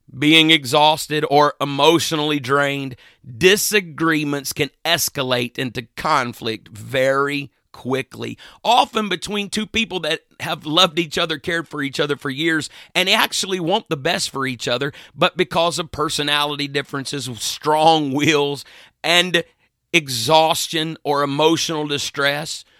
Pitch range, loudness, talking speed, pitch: 140-165 Hz, -18 LUFS, 125 wpm, 150 Hz